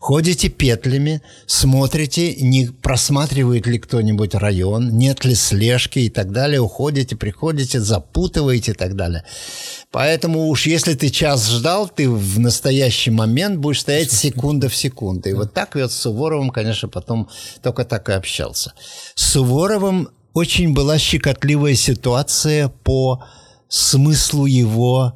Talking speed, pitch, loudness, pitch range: 135 wpm, 130 Hz, -17 LUFS, 115-145 Hz